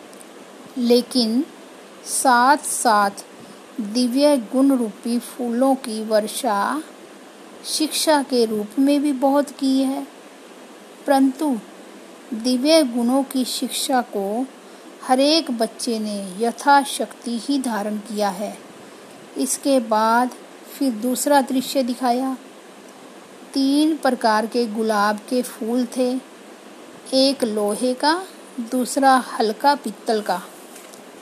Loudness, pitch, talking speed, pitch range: -20 LUFS, 255 Hz, 100 wpm, 230-275 Hz